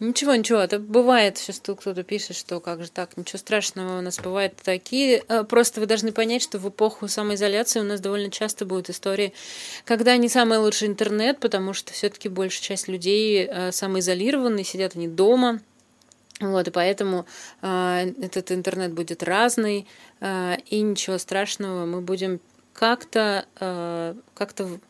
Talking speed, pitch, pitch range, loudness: 145 wpm, 200 Hz, 185-220 Hz, -23 LUFS